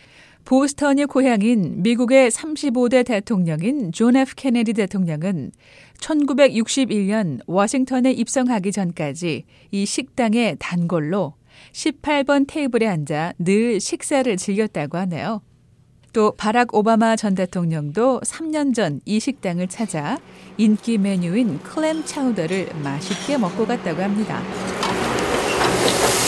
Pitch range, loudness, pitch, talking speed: 185-260 Hz, -20 LUFS, 220 Hz, 235 characters per minute